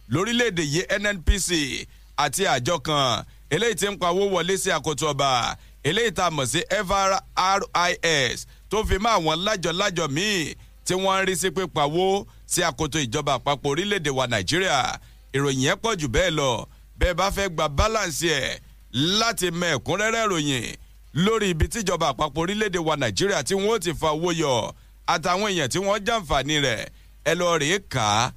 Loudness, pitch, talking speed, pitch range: -23 LUFS, 175 Hz, 135 wpm, 150-195 Hz